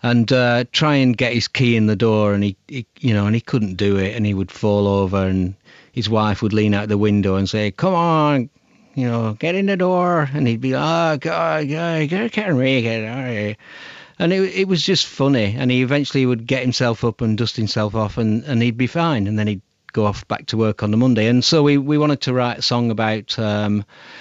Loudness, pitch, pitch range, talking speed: -18 LUFS, 120 Hz, 105-145 Hz, 240 wpm